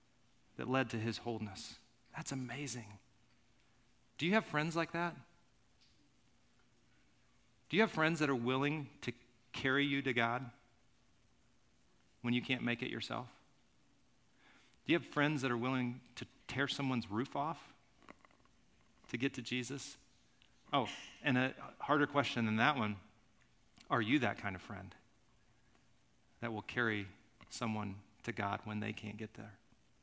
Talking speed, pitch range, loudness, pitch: 145 wpm, 110-140 Hz, -38 LUFS, 120 Hz